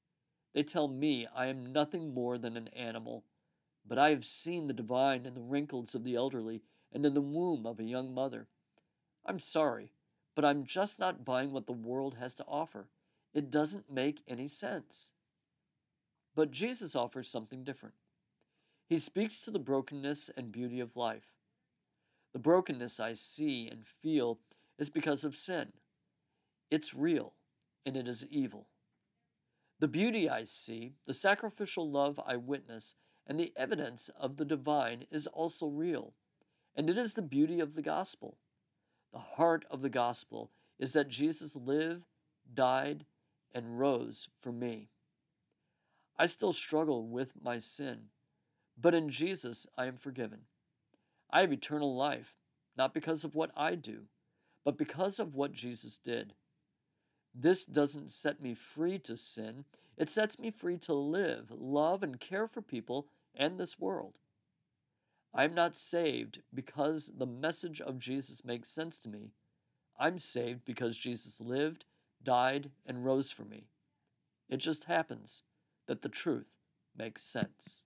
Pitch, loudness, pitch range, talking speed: 140 Hz, -36 LUFS, 125-155 Hz, 155 wpm